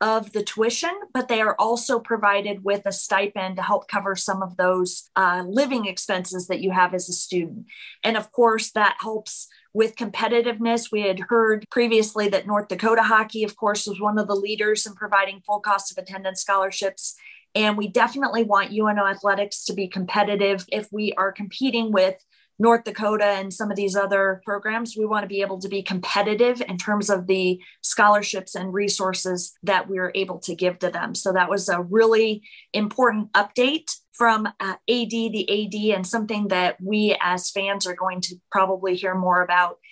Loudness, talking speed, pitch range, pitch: -22 LUFS, 185 wpm, 190-220 Hz, 205 Hz